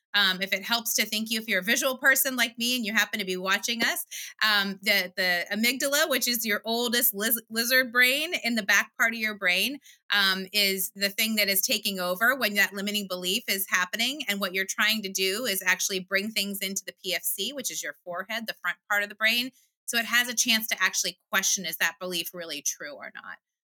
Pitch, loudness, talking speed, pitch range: 205 Hz, -25 LUFS, 230 wpm, 190-235 Hz